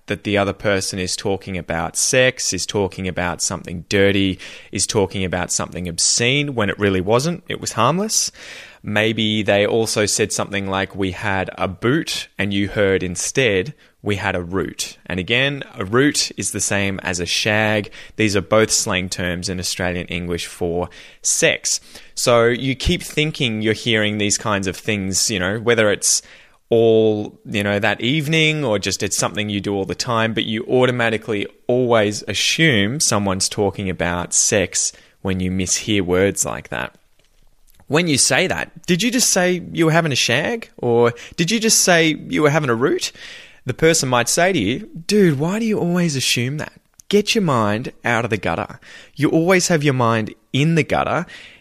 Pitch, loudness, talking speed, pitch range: 110 Hz, -18 LUFS, 185 wpm, 95-140 Hz